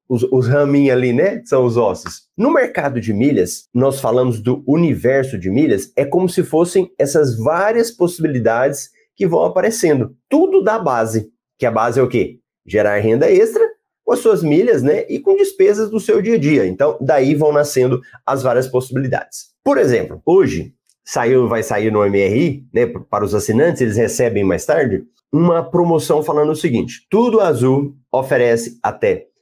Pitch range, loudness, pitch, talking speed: 125-205 Hz, -15 LUFS, 145 Hz, 175 wpm